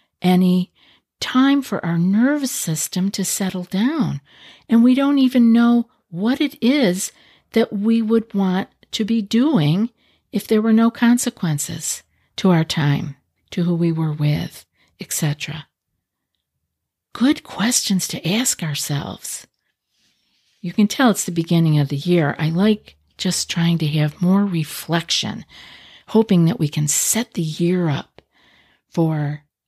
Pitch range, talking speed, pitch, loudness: 160-230 Hz, 140 wpm, 185 Hz, -19 LUFS